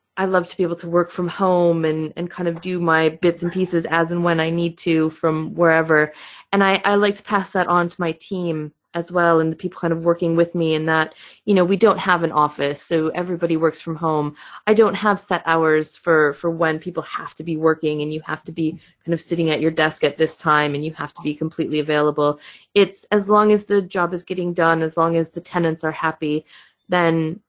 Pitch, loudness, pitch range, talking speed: 165 Hz, -20 LUFS, 160-180 Hz, 245 wpm